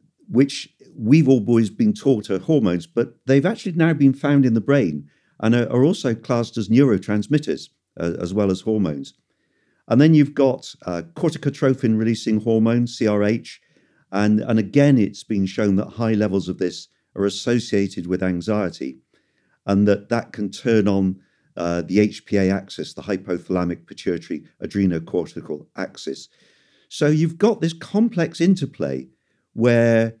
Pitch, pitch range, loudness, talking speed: 110 Hz, 95-135 Hz, -20 LUFS, 145 wpm